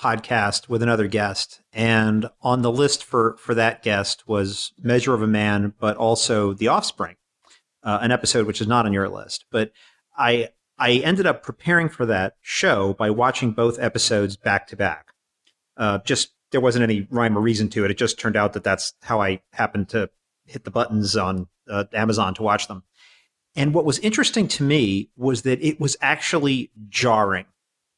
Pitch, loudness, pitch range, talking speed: 115 Hz, -21 LUFS, 105-120 Hz, 185 wpm